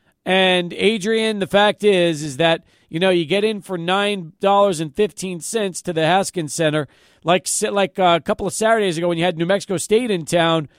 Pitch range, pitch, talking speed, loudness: 170-200 Hz, 185 Hz, 205 wpm, -18 LUFS